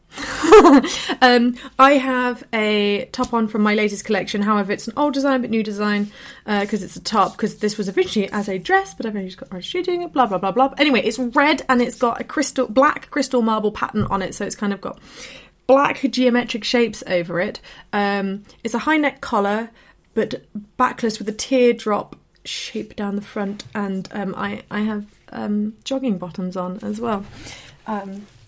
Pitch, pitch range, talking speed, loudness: 215 Hz, 205-255 Hz, 190 wpm, -20 LUFS